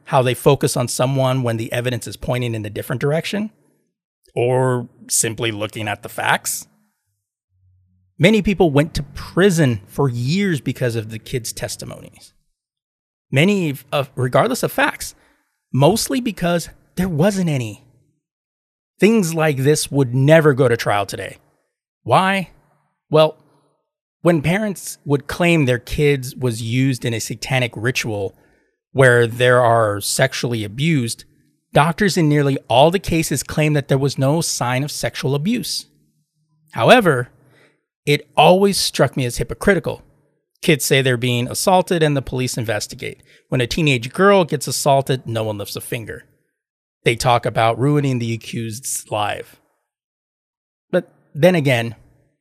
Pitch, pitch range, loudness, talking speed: 140 Hz, 120-155 Hz, -18 LUFS, 140 wpm